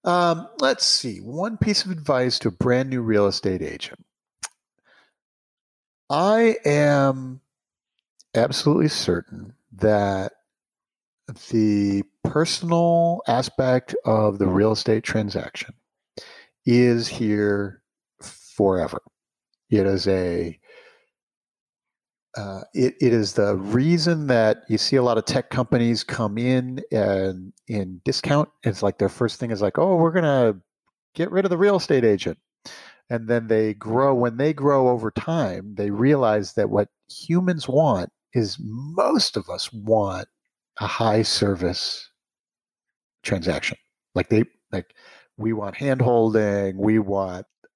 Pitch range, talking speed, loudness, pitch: 105-140 Hz, 125 wpm, -22 LUFS, 115 Hz